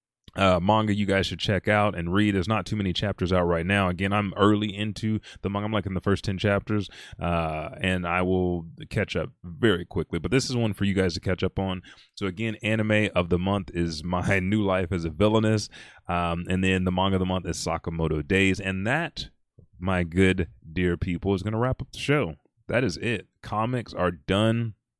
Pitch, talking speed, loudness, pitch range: 95 Hz, 220 wpm, -26 LUFS, 90-105 Hz